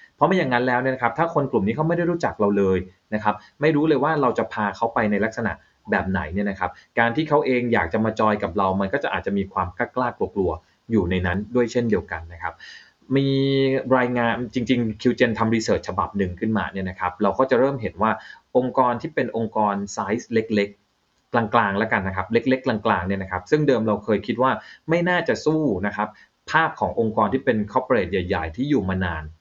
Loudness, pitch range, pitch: -22 LUFS, 100-130 Hz, 110 Hz